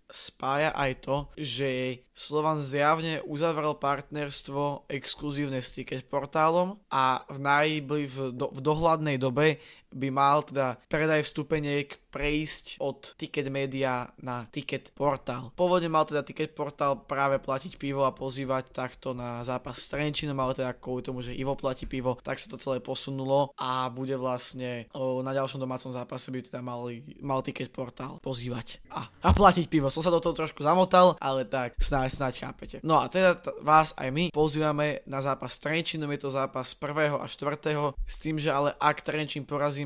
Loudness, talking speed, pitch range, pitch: -29 LUFS, 170 wpm, 130-150 Hz, 140 Hz